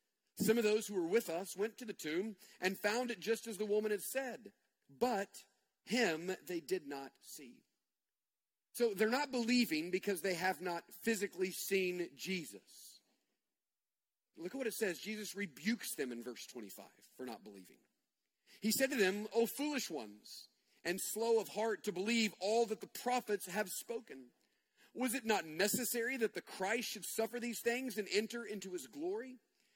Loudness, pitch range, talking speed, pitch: -38 LUFS, 185-235 Hz, 175 wpm, 215 Hz